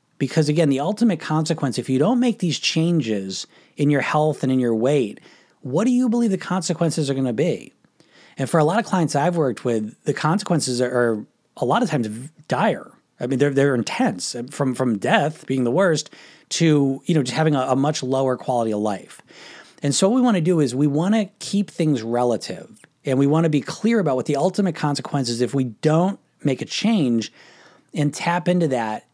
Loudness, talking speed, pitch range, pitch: -21 LUFS, 215 wpm, 130-170 Hz, 145 Hz